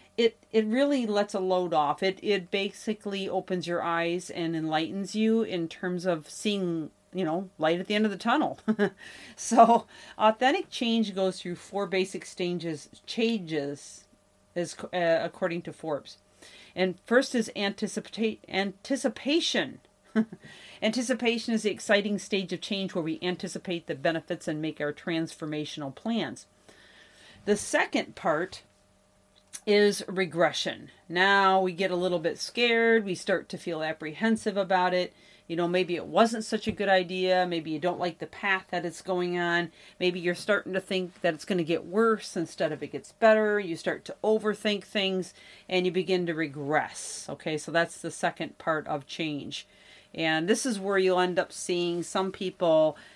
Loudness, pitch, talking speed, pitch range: -28 LUFS, 185 Hz, 165 wpm, 170-210 Hz